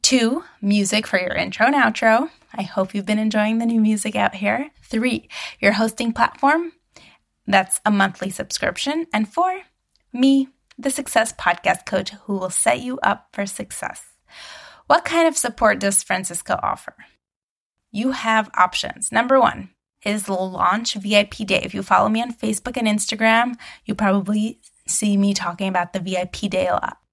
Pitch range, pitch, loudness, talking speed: 200-245 Hz, 215 Hz, -20 LUFS, 165 wpm